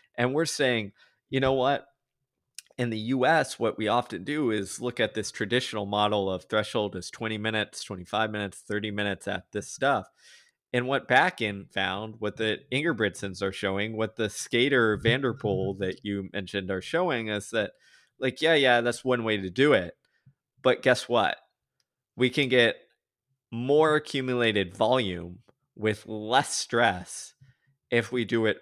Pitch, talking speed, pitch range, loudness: 110 Hz, 165 wpm, 105-125 Hz, -27 LUFS